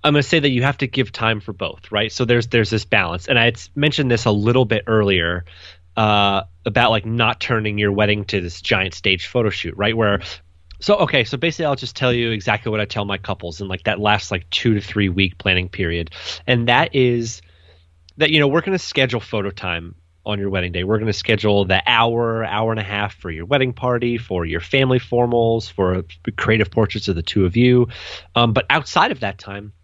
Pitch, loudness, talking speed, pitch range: 105 Hz, -18 LUFS, 225 wpm, 95-120 Hz